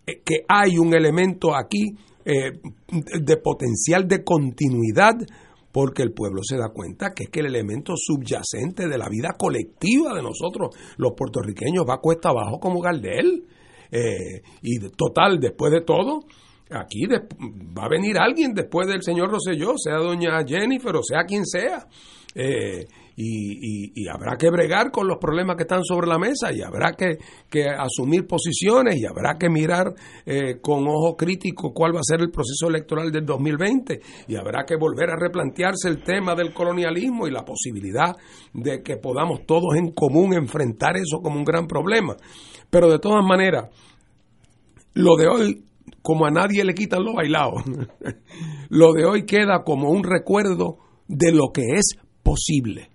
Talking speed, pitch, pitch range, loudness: 170 wpm, 165 Hz, 145-180 Hz, -21 LUFS